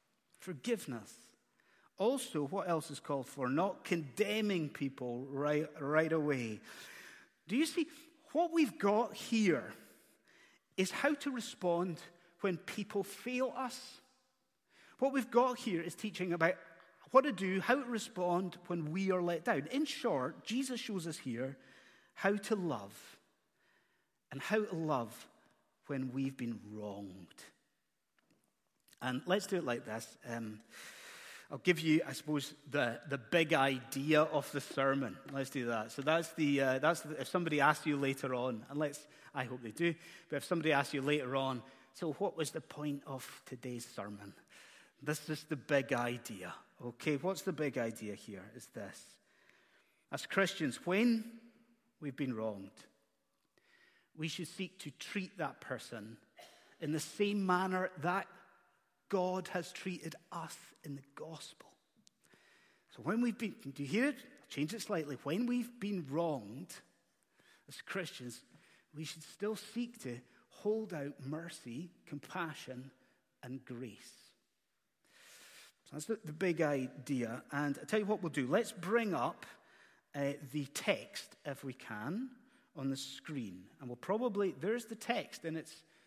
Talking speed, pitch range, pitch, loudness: 150 wpm, 135-200 Hz, 160 Hz, -37 LUFS